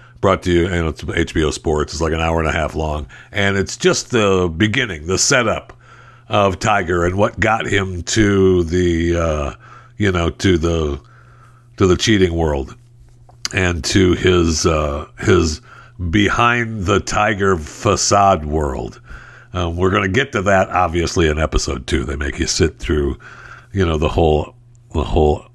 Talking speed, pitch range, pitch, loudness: 165 wpm, 80-110 Hz, 95 Hz, -17 LUFS